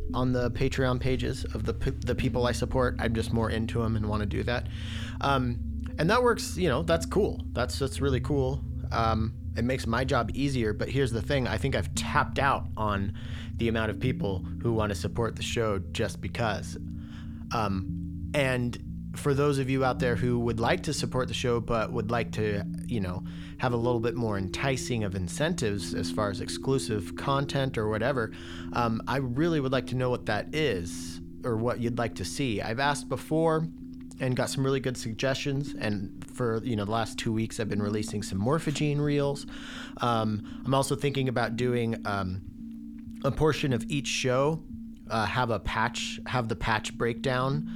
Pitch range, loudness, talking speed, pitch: 100-130 Hz, -29 LUFS, 195 wpm, 115 Hz